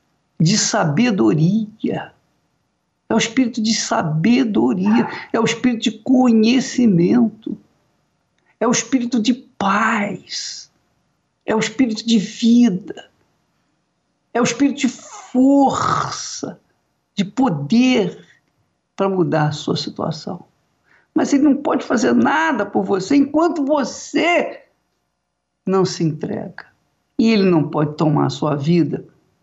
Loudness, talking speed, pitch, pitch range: -17 LUFS, 110 wpm, 225 Hz, 190-255 Hz